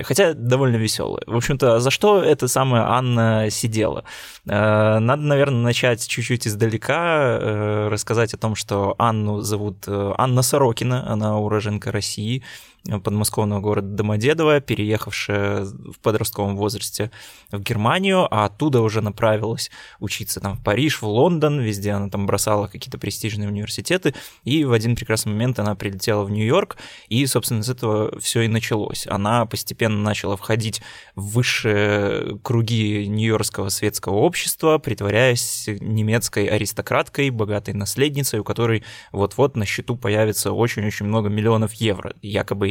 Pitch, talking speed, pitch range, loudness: 110 Hz, 135 wpm, 105-120 Hz, -20 LUFS